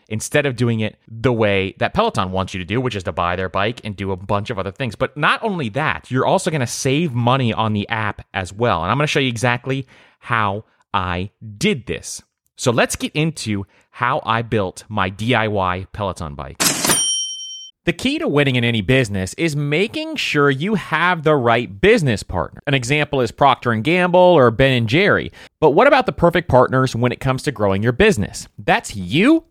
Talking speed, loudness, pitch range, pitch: 205 wpm, -18 LUFS, 105-150 Hz, 120 Hz